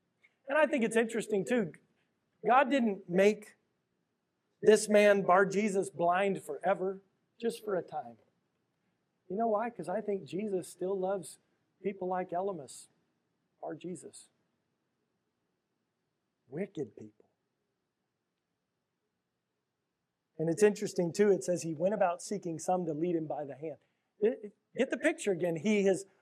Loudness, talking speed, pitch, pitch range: -31 LUFS, 135 wpm, 195 Hz, 175-210 Hz